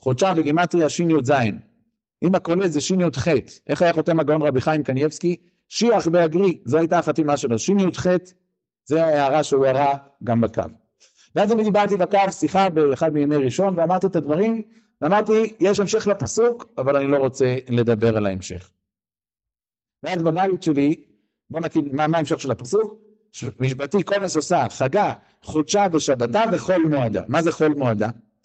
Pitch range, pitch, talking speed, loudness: 140-185 Hz, 160 Hz, 155 wpm, -20 LUFS